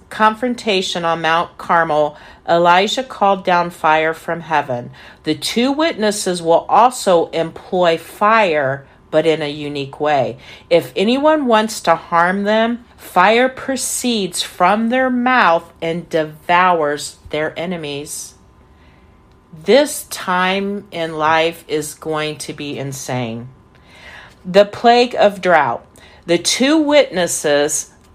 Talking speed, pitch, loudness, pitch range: 115 wpm, 170 Hz, -16 LUFS, 155-210 Hz